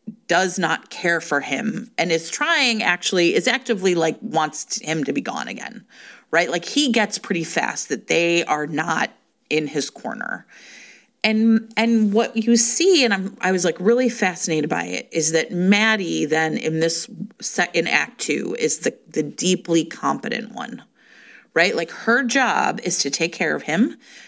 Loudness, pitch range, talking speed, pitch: -20 LUFS, 165-225 Hz, 175 wpm, 185 Hz